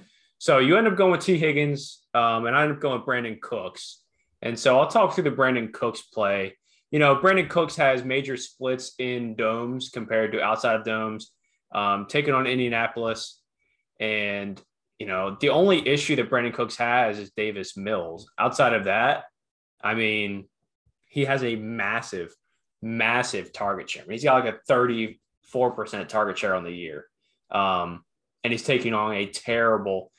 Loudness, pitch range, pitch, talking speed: -24 LUFS, 105-130 Hz, 115 Hz, 175 wpm